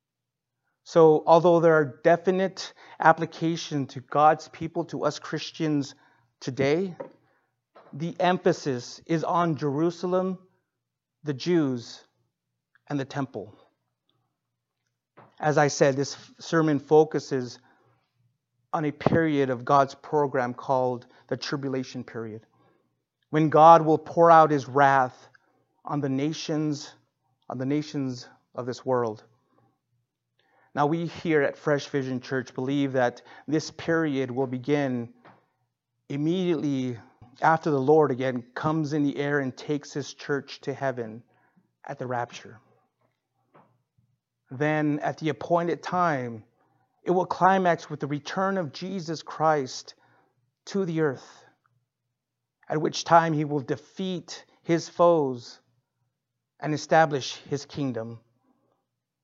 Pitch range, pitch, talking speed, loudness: 130-160 Hz, 145 Hz, 115 wpm, -25 LUFS